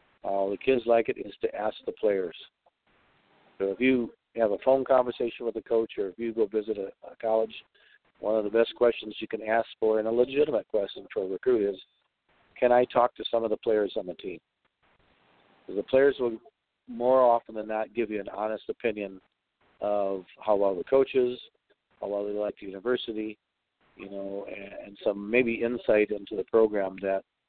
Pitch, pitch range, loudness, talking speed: 115 Hz, 105-125 Hz, -28 LUFS, 200 wpm